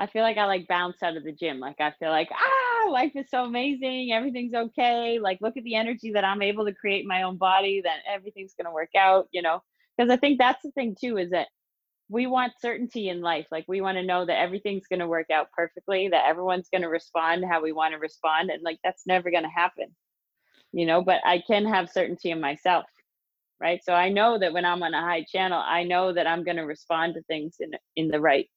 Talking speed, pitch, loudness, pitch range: 240 wpm, 185 Hz, -25 LUFS, 165-220 Hz